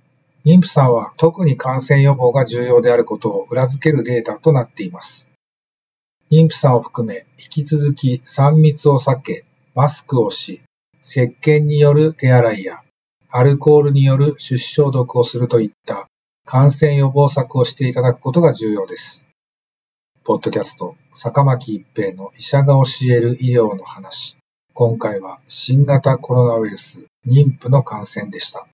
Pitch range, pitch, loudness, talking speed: 125-145 Hz, 135 Hz, -15 LUFS, 300 characters per minute